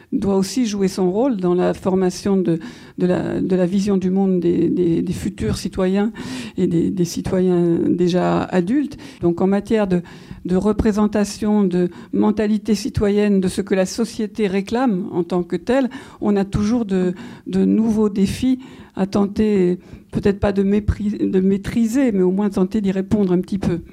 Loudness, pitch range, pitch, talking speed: -19 LUFS, 180-215 Hz, 195 Hz, 175 wpm